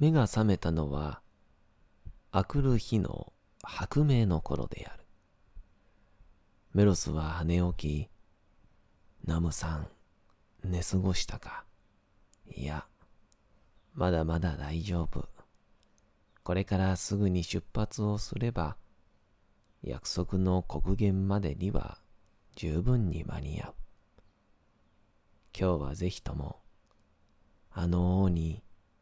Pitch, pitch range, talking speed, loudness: 95 Hz, 85-105 Hz, 180 characters per minute, -32 LUFS